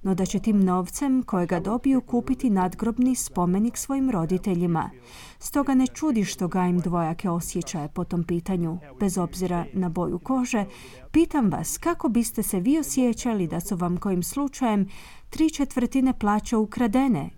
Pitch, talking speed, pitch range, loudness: 200 Hz, 150 wpm, 180-255 Hz, -25 LUFS